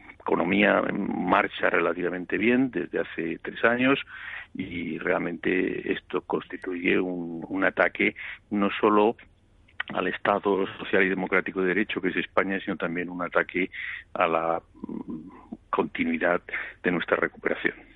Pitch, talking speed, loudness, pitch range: 100 Hz, 125 wpm, -26 LUFS, 90-115 Hz